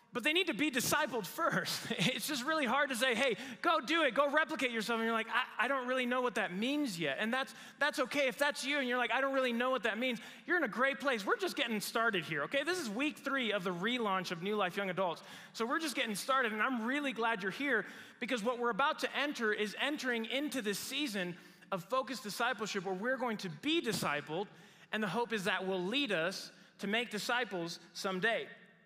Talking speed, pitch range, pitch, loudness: 240 wpm, 205-275 Hz, 245 Hz, -34 LUFS